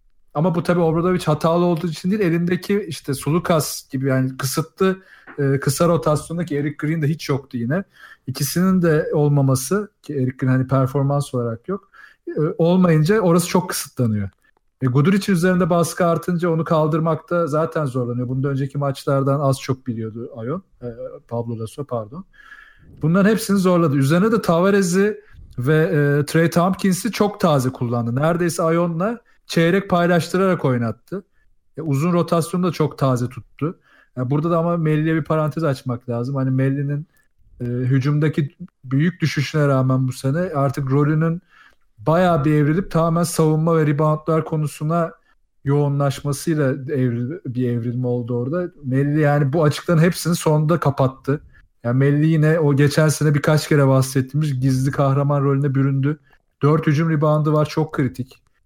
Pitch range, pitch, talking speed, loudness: 135-170 Hz, 150 Hz, 145 wpm, -19 LUFS